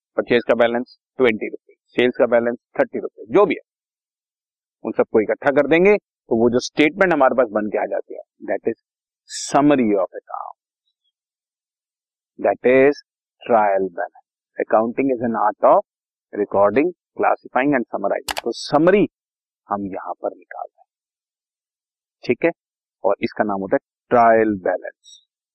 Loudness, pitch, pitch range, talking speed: -19 LUFS, 120 Hz, 105-145 Hz, 130 wpm